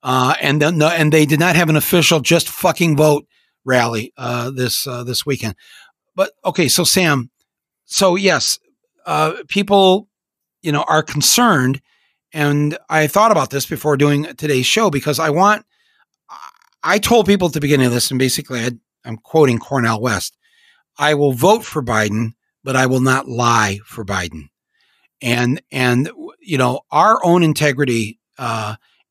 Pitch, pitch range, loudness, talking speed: 150 Hz, 125-175 Hz, -16 LUFS, 160 wpm